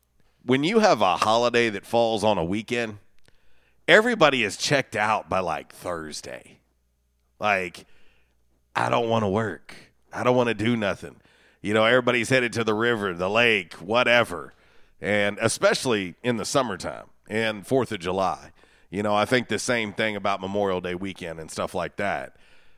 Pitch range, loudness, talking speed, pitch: 90-115 Hz, -23 LUFS, 165 wpm, 105 Hz